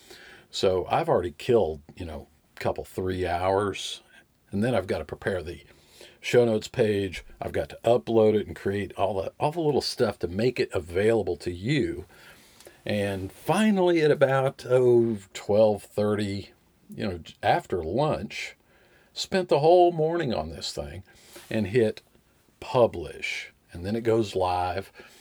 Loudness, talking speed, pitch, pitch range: -26 LUFS, 150 wpm, 105 Hz, 95-125 Hz